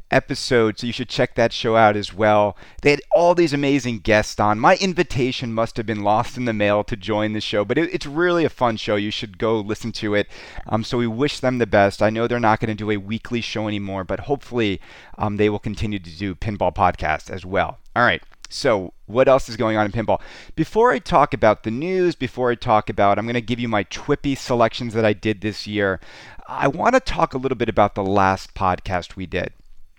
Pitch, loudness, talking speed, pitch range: 110 Hz, -20 LUFS, 240 wpm, 105-125 Hz